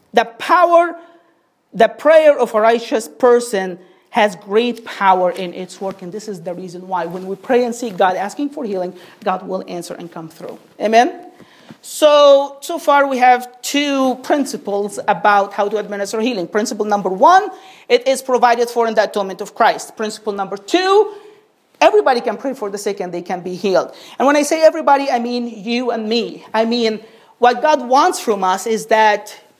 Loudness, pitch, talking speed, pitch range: -16 LUFS, 225 Hz, 190 wpm, 200-275 Hz